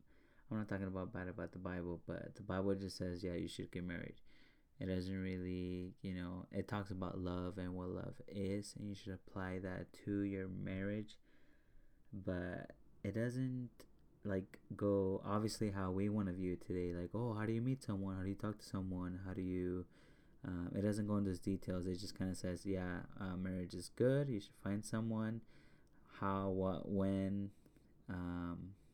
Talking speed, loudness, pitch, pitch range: 195 wpm, -43 LUFS, 95 Hz, 90-105 Hz